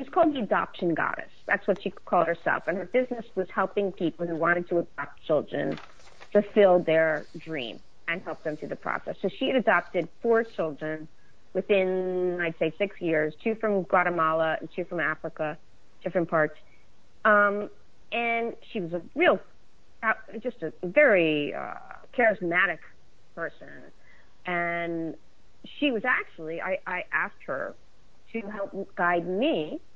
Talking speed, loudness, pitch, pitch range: 150 wpm, -27 LUFS, 180 Hz, 160-205 Hz